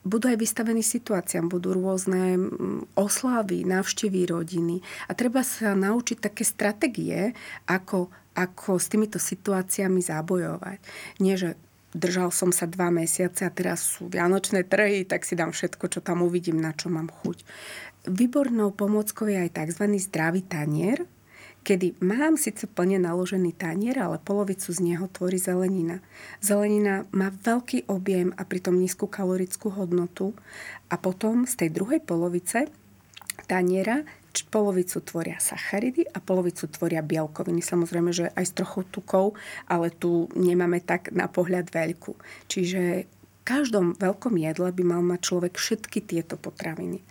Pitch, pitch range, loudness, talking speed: 185 Hz, 175-205 Hz, -26 LUFS, 140 wpm